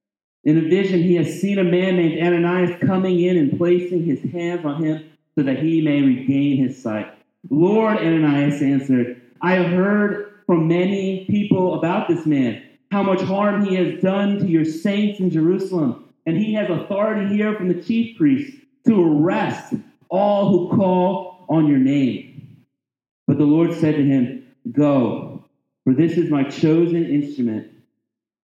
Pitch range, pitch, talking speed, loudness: 145-190 Hz, 170 Hz, 165 wpm, -19 LUFS